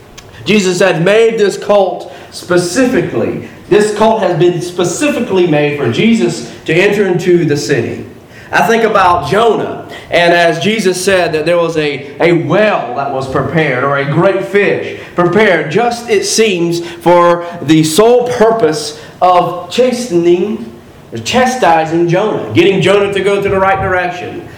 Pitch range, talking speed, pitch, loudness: 155-200 Hz, 150 wpm, 175 Hz, -11 LUFS